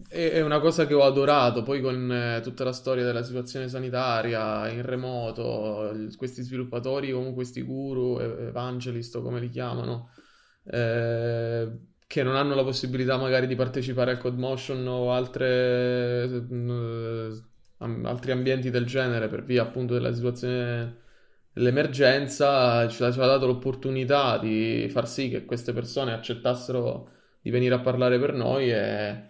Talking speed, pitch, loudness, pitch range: 145 wpm, 125 Hz, -26 LUFS, 120-130 Hz